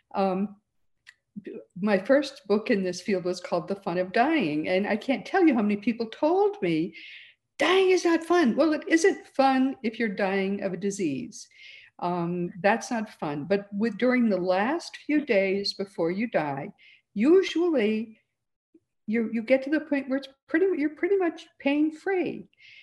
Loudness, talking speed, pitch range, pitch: -26 LUFS, 175 wpm, 195-310 Hz, 235 Hz